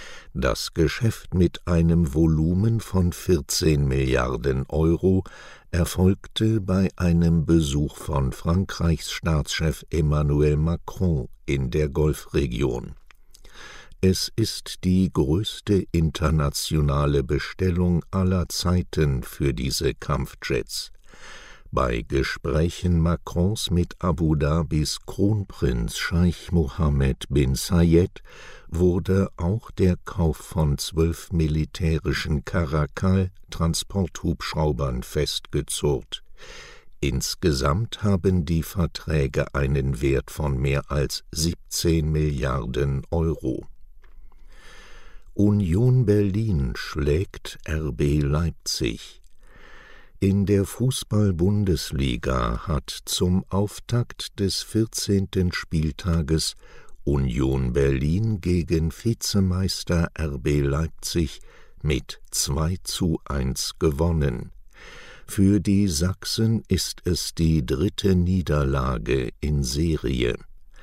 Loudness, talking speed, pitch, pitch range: -24 LUFS, 85 wpm, 80 Hz, 75-95 Hz